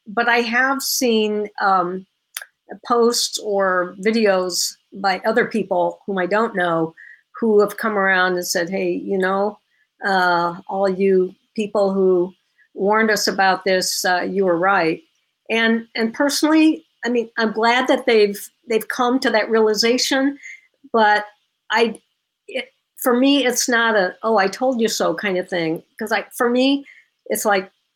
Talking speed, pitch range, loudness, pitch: 155 wpm, 190-235 Hz, -19 LUFS, 215 Hz